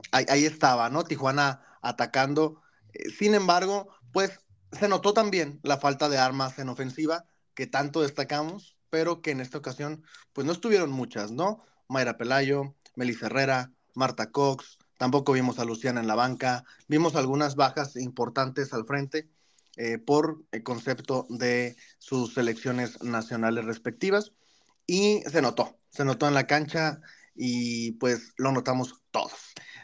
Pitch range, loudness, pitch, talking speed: 125-155 Hz, -28 LUFS, 135 Hz, 145 wpm